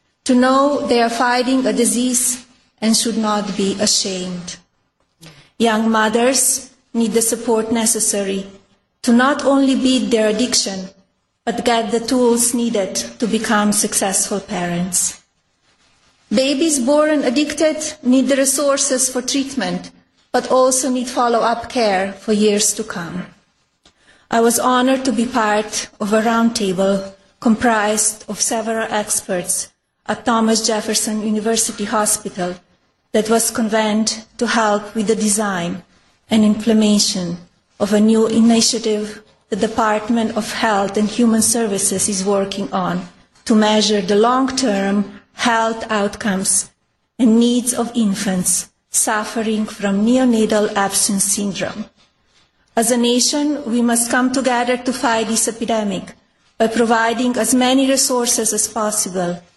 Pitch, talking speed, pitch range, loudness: 225 Hz, 125 wpm, 205-245 Hz, -16 LUFS